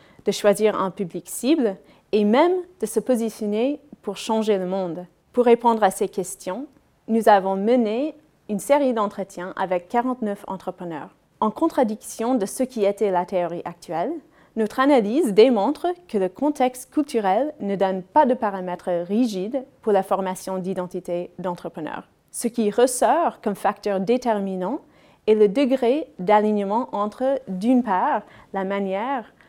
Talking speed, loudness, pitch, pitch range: 140 wpm, -22 LUFS, 210 Hz, 190-255 Hz